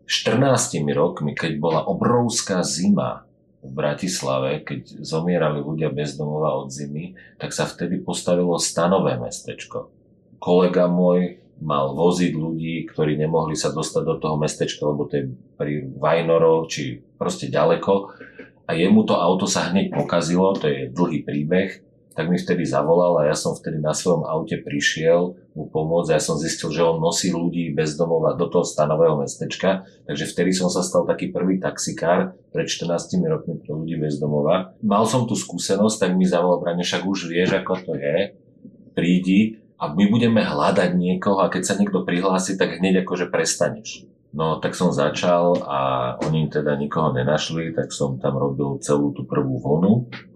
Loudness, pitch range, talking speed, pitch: -21 LUFS, 75-90 Hz, 165 wpm, 85 Hz